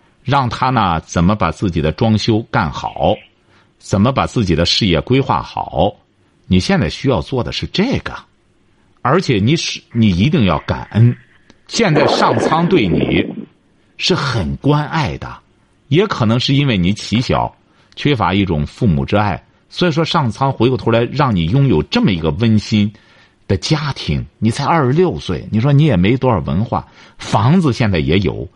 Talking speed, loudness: 240 characters per minute, -15 LUFS